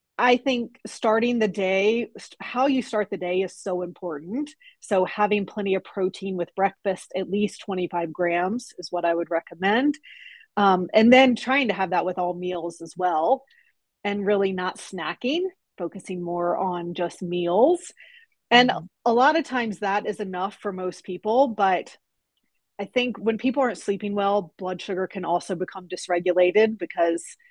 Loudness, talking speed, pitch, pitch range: -24 LUFS, 165 wpm, 195 Hz, 180-240 Hz